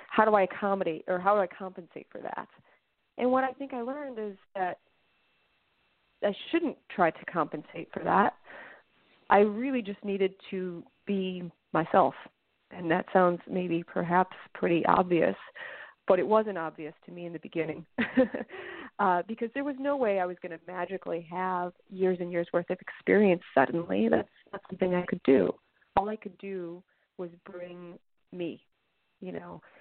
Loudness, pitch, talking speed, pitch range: -29 LUFS, 185 Hz, 165 wpm, 175-210 Hz